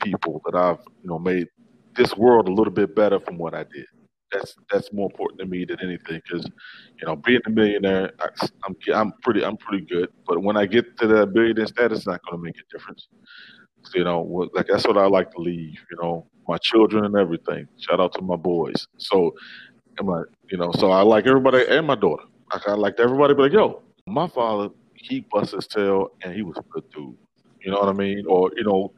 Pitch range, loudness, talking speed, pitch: 90-110 Hz, -21 LUFS, 230 wpm, 100 Hz